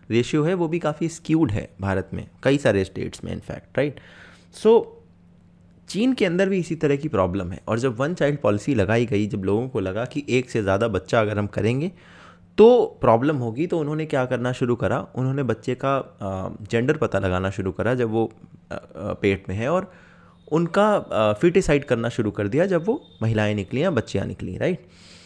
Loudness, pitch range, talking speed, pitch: -22 LUFS, 100-155 Hz, 195 wpm, 120 Hz